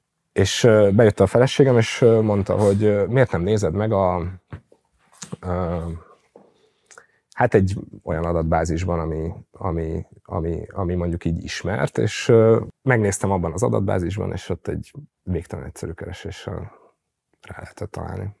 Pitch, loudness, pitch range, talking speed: 95 Hz, -20 LUFS, 85-105 Hz, 125 wpm